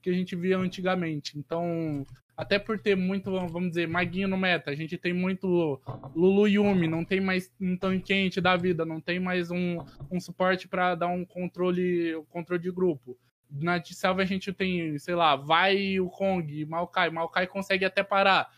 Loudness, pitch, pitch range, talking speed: -27 LUFS, 180 Hz, 165-190 Hz, 190 wpm